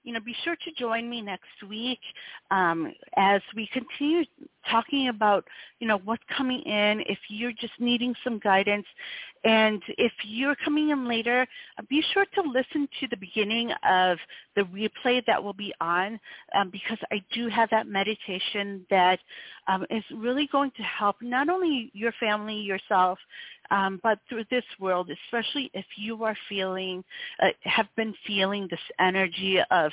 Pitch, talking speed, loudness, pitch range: 220 Hz, 165 wpm, -27 LUFS, 195-250 Hz